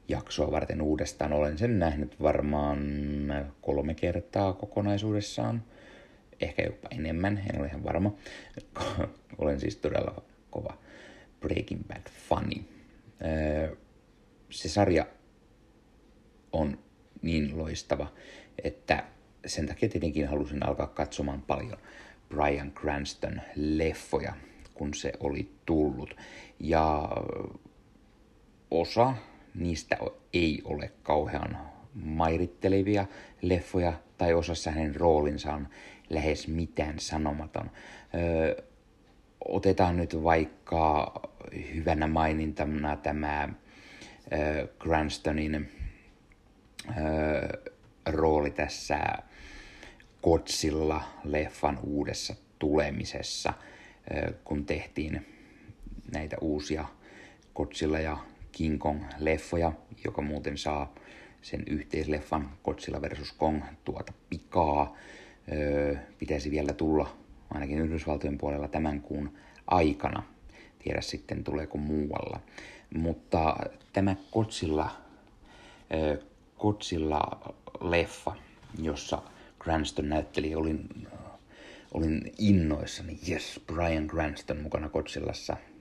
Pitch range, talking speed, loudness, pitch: 75-85 Hz, 85 wpm, -31 LUFS, 75 Hz